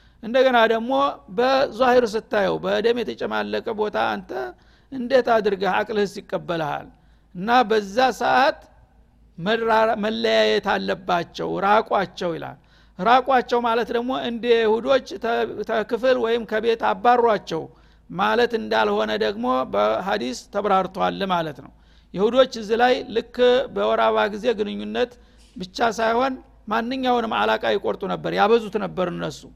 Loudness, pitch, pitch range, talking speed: -21 LUFS, 225 Hz, 205-245 Hz, 105 wpm